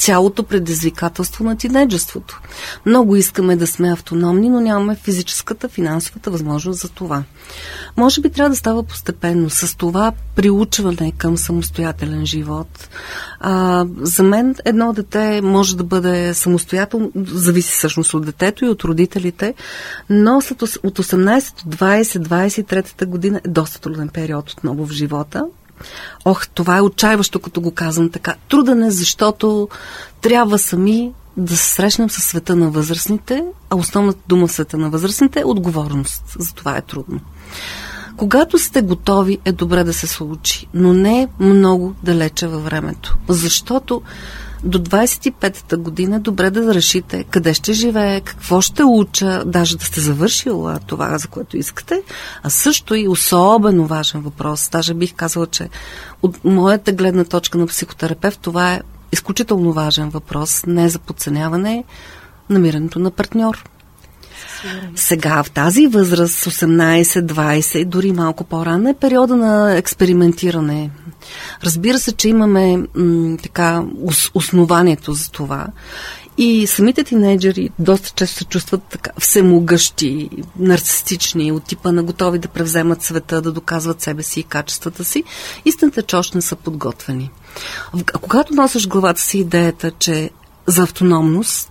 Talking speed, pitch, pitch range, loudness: 140 wpm, 180 Hz, 165-205 Hz, -15 LUFS